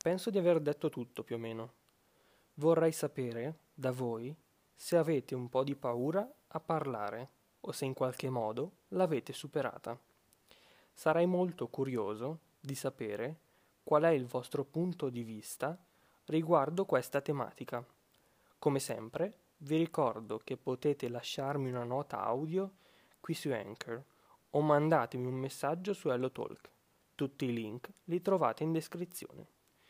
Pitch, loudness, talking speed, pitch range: 140 Hz, -36 LUFS, 135 wpm, 125-165 Hz